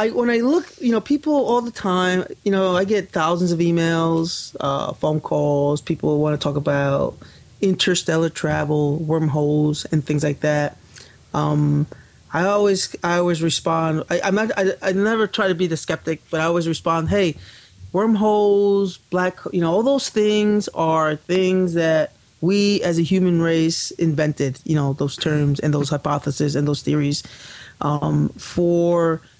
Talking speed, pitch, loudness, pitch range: 165 wpm, 165 Hz, -20 LUFS, 150-190 Hz